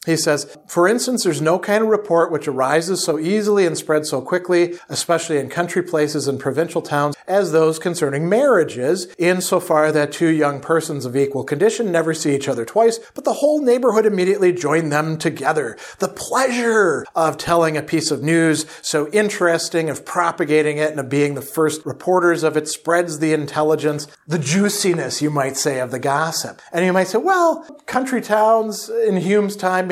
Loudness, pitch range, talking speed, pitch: -18 LUFS, 150-190 Hz, 185 wpm, 165 Hz